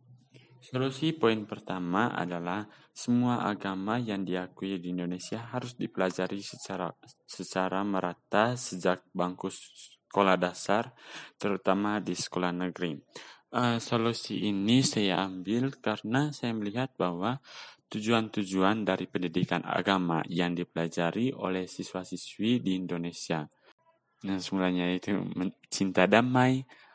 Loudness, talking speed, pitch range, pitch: -30 LUFS, 105 wpm, 90-115 Hz, 95 Hz